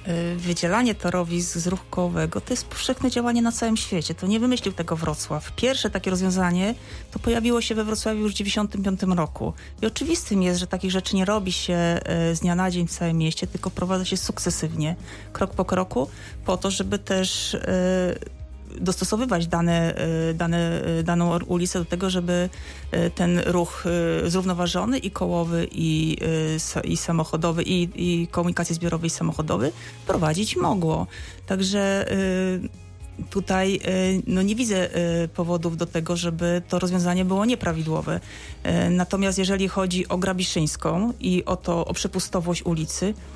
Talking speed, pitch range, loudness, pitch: 145 wpm, 170-190 Hz, -24 LUFS, 180 Hz